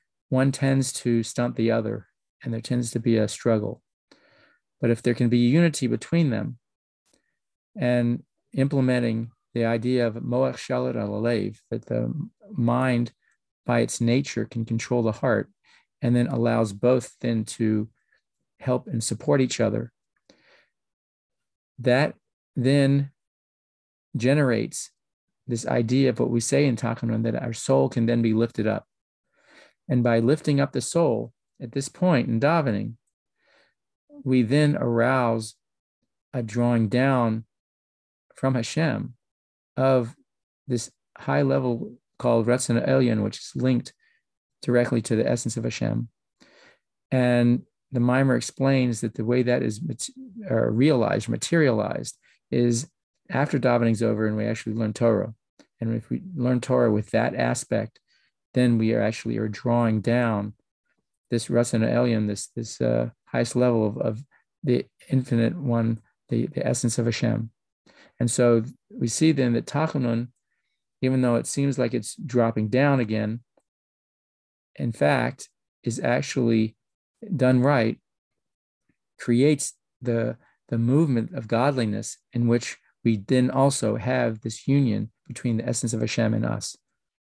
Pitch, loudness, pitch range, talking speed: 120 Hz, -24 LUFS, 115-130 Hz, 135 wpm